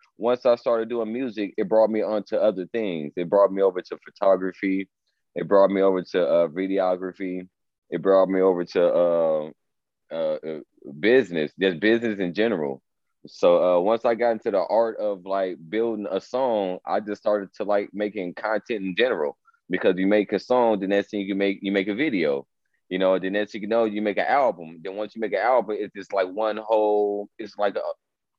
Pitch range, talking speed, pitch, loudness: 95-110 Hz, 205 wpm, 100 Hz, -23 LUFS